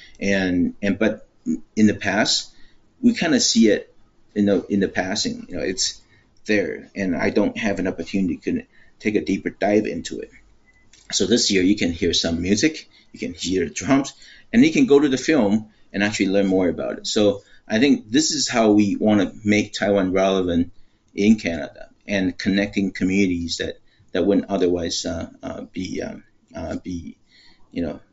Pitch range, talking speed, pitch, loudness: 95-115 Hz, 185 wpm, 105 Hz, -21 LUFS